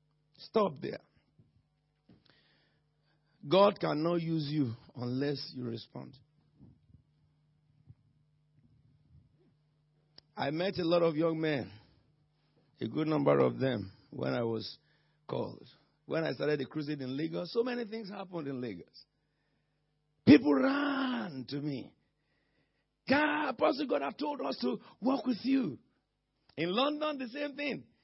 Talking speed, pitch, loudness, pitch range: 120 wpm, 150 Hz, -32 LUFS, 140-175 Hz